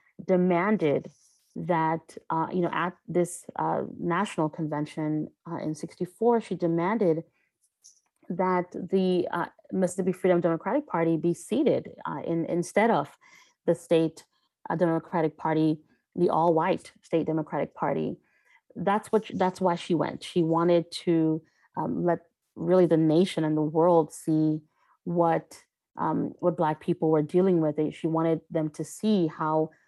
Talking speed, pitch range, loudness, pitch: 145 wpm, 160-180 Hz, -27 LUFS, 170 Hz